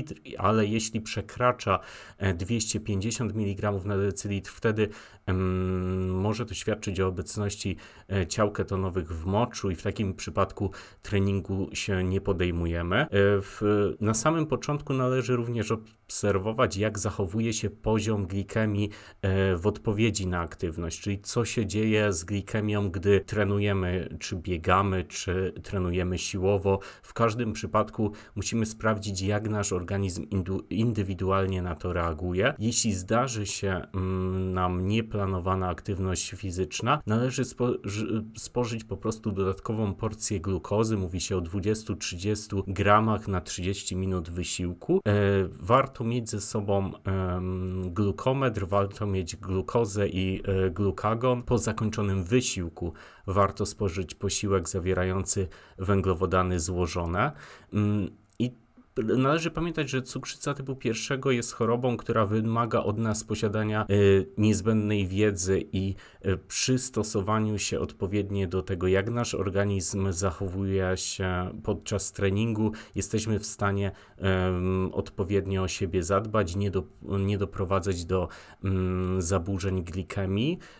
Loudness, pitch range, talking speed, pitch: -28 LUFS, 95-110 Hz, 115 wpm, 100 Hz